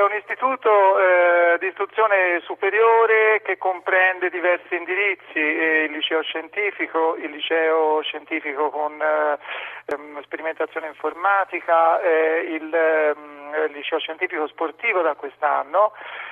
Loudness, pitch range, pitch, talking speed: -20 LUFS, 155-190 Hz, 165 Hz, 115 wpm